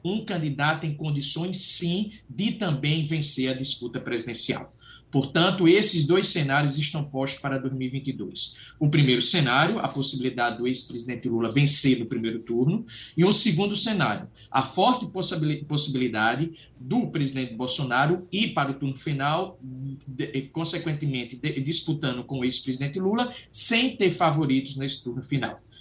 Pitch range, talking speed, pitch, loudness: 130-170 Hz, 135 wpm, 145 Hz, -26 LUFS